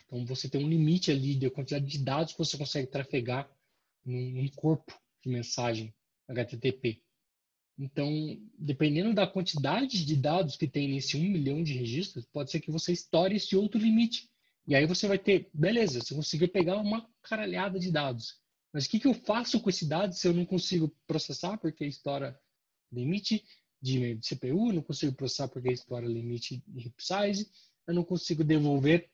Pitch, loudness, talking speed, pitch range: 155 Hz, -31 LUFS, 175 wpm, 135-185 Hz